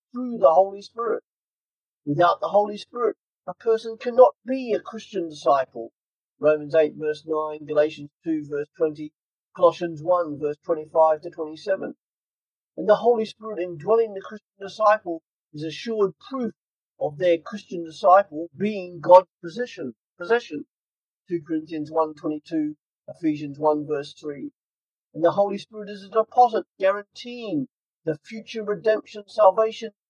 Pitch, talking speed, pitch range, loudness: 180 Hz, 130 wpm, 155-215 Hz, -23 LUFS